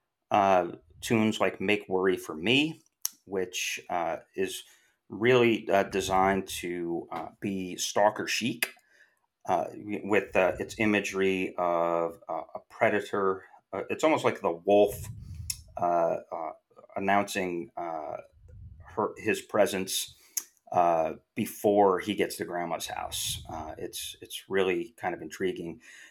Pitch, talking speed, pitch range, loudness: 95 Hz, 125 wpm, 95-105 Hz, -29 LUFS